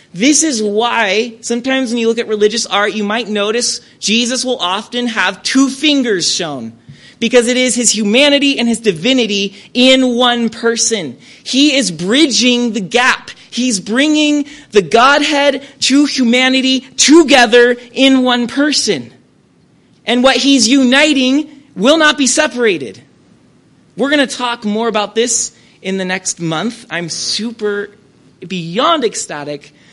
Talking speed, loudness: 140 wpm, -12 LUFS